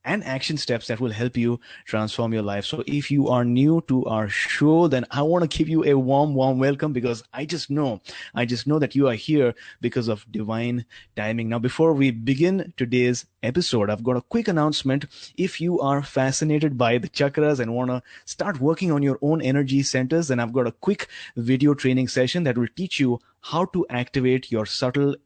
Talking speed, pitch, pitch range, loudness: 210 wpm, 130 Hz, 120-150 Hz, -23 LUFS